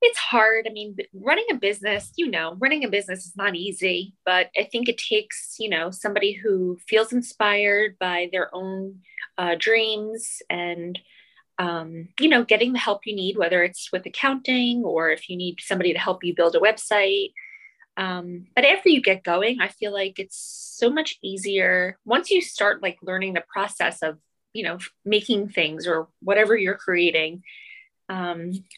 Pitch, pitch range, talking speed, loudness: 200 Hz, 180-230 Hz, 175 wpm, -22 LUFS